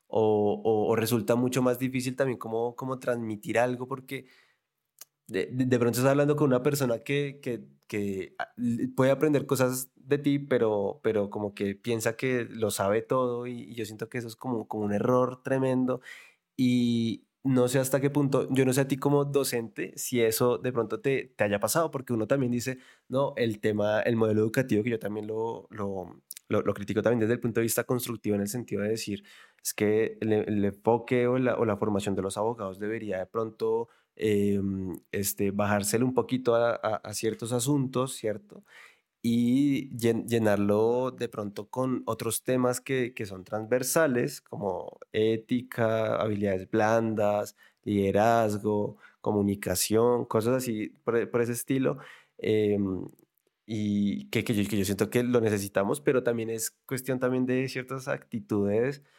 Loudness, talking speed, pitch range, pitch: -28 LUFS, 175 wpm, 105-130 Hz, 115 Hz